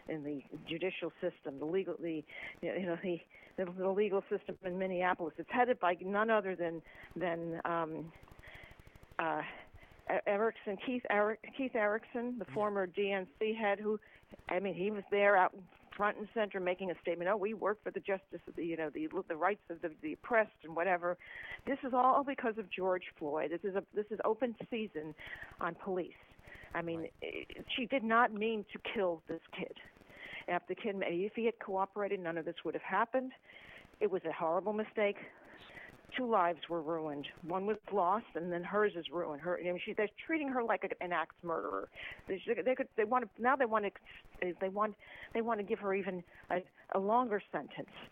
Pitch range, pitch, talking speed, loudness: 175-215 Hz, 195 Hz, 190 wpm, -37 LUFS